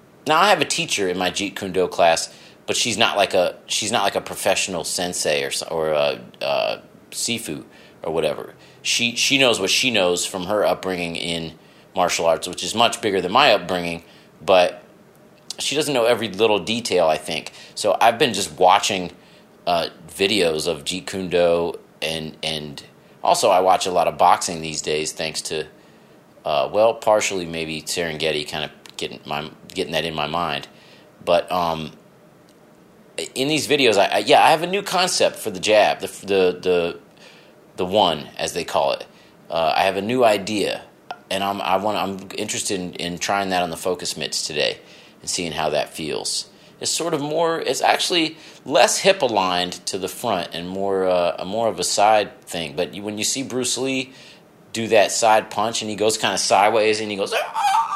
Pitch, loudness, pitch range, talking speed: 95 Hz, -20 LUFS, 85-120 Hz, 195 wpm